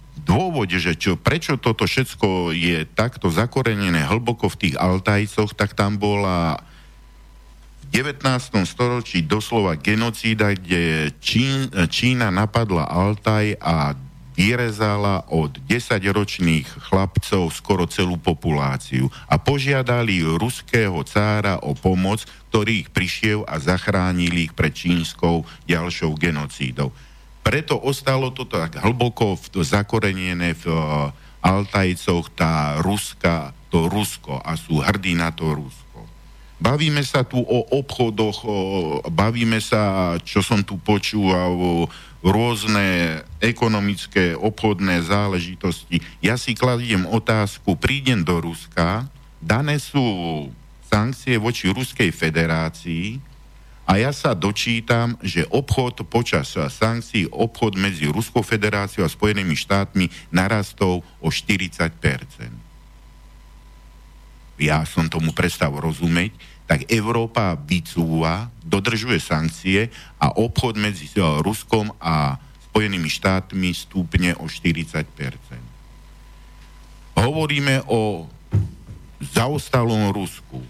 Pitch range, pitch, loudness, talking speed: 85-115 Hz, 100 Hz, -21 LUFS, 105 wpm